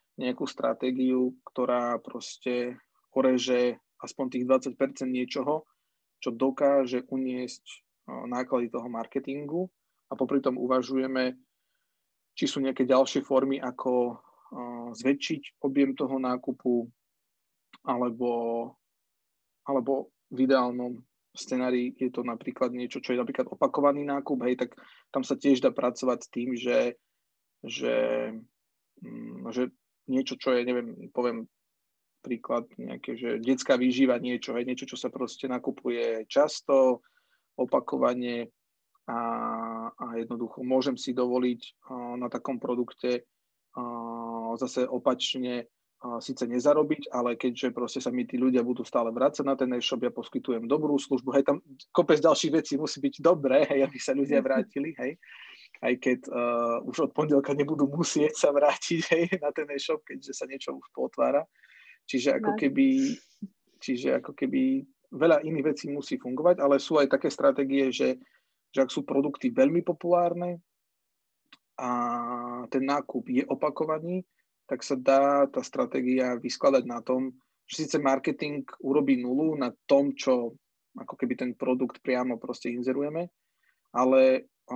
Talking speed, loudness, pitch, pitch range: 135 wpm, -28 LUFS, 130 Hz, 125-140 Hz